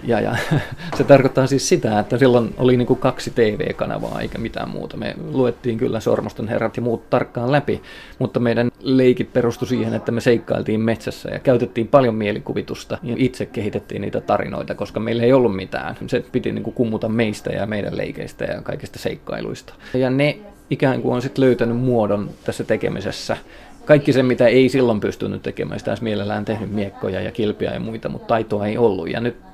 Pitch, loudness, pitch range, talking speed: 120 Hz, -20 LUFS, 110-130 Hz, 180 wpm